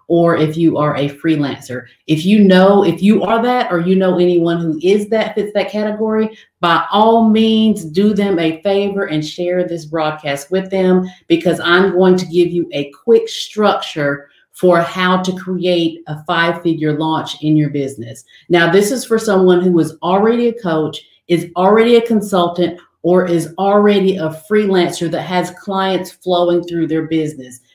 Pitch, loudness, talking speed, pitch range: 175 Hz, -14 LUFS, 175 wpm, 160-195 Hz